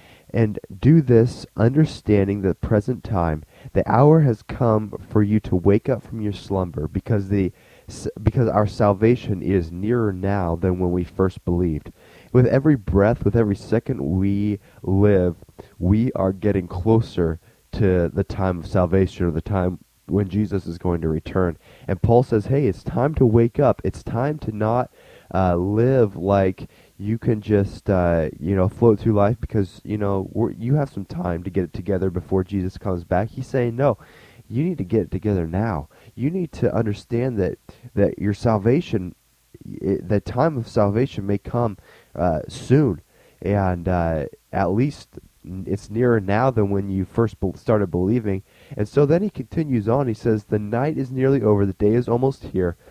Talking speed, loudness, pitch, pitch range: 180 wpm, -21 LUFS, 105 Hz, 95-115 Hz